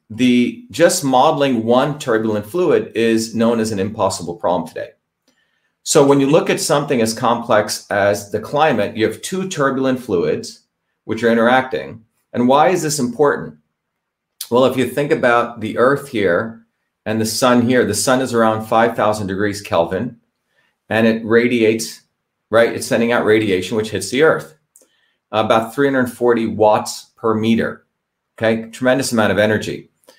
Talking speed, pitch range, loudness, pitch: 155 wpm, 110-130 Hz, -16 LUFS, 115 Hz